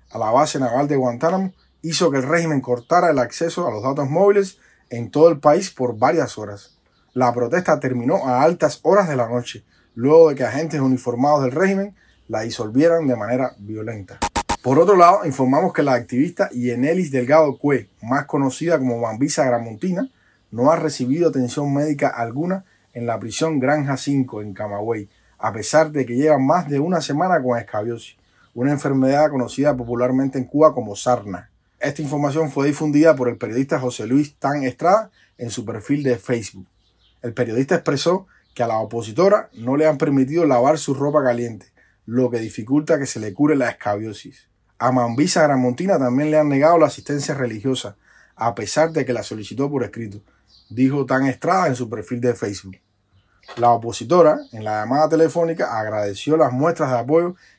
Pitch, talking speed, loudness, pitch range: 130 Hz, 175 wpm, -19 LUFS, 120-155 Hz